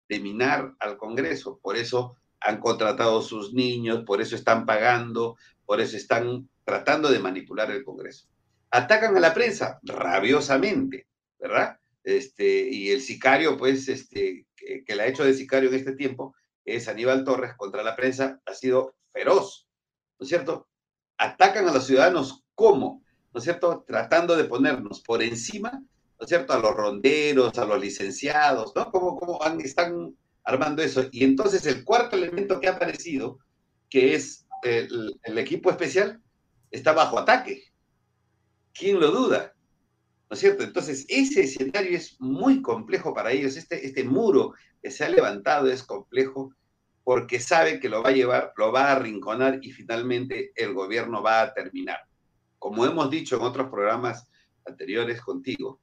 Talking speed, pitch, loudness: 160 wpm, 135 Hz, -24 LUFS